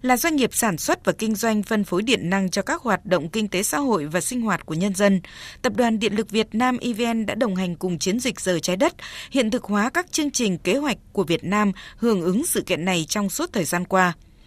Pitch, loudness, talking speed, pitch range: 210 Hz, -22 LUFS, 260 wpm, 185-240 Hz